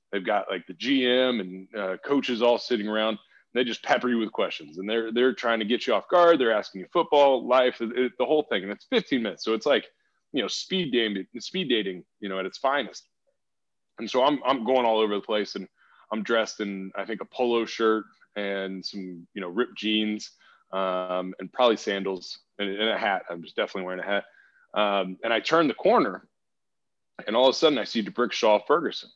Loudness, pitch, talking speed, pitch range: -26 LUFS, 110 Hz, 220 wpm, 95-125 Hz